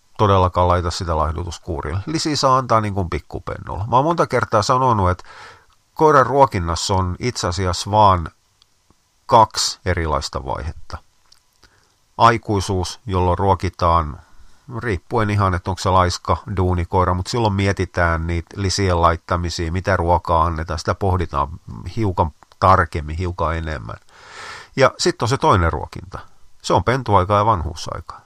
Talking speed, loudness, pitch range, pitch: 125 wpm, -19 LUFS, 90-105 Hz, 95 Hz